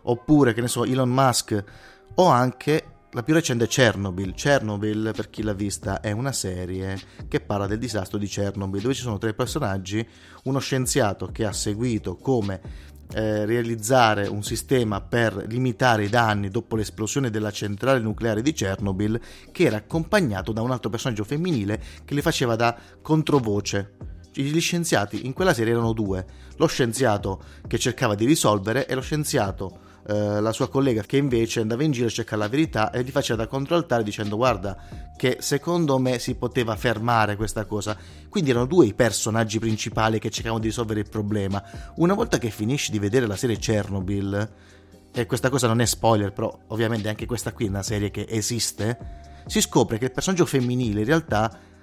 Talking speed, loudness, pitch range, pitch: 175 wpm, -24 LUFS, 105-130 Hz, 115 Hz